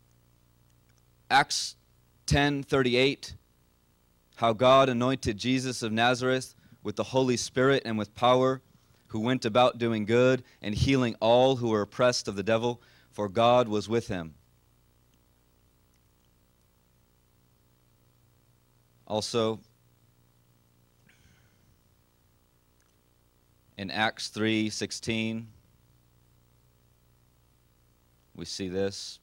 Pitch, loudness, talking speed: 100 Hz, -27 LUFS, 85 wpm